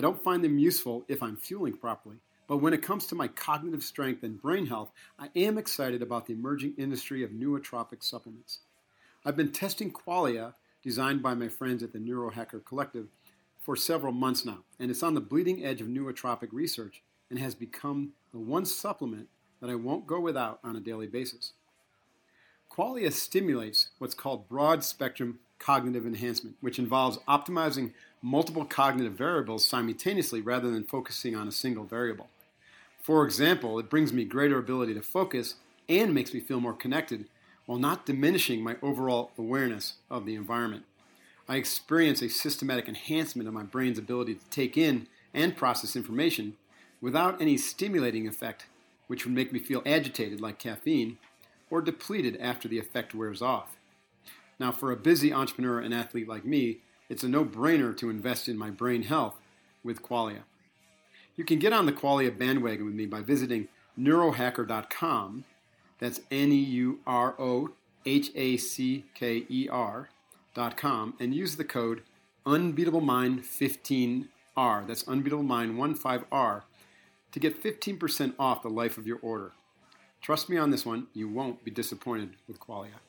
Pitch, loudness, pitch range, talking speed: 125 Hz, -30 LUFS, 115-145 Hz, 160 wpm